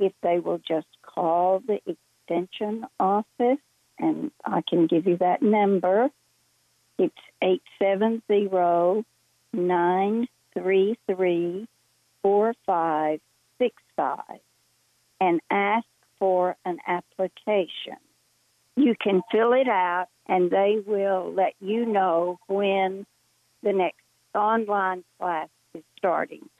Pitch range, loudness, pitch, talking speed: 180-215 Hz, -25 LUFS, 190 Hz, 90 wpm